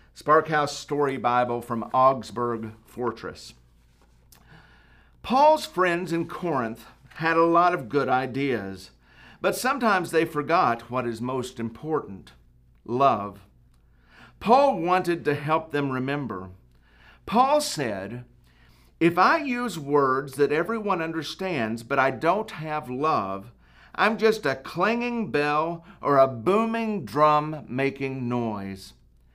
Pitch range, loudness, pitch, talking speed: 115-170 Hz, -24 LUFS, 140 Hz, 115 wpm